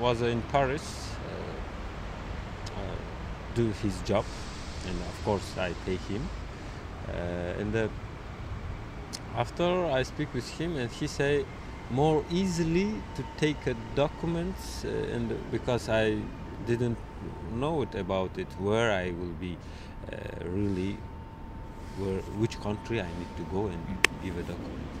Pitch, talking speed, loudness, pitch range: 100 Hz, 135 wpm, -32 LUFS, 90-120 Hz